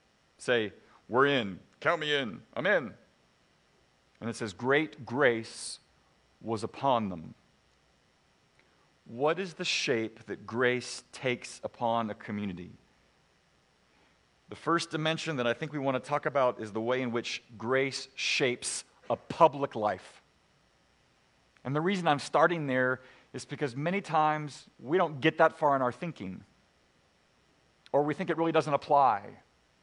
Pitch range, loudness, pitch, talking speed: 115-155 Hz, -30 LUFS, 130 Hz, 145 wpm